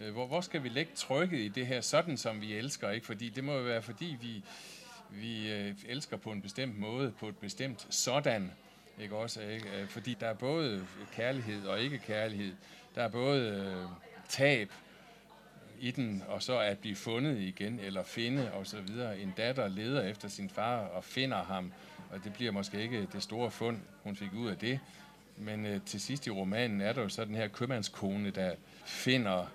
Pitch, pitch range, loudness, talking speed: 110 Hz, 100-130 Hz, -36 LUFS, 185 wpm